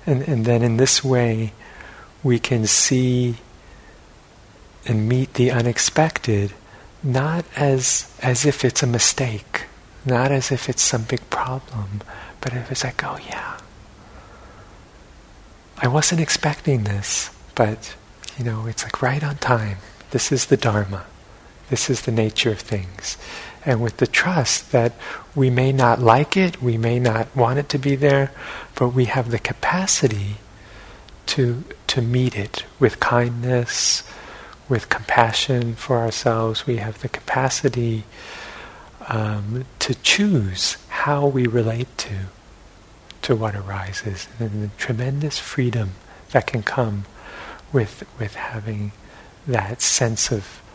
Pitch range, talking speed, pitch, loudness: 110-130 Hz, 135 wpm, 120 Hz, -20 LUFS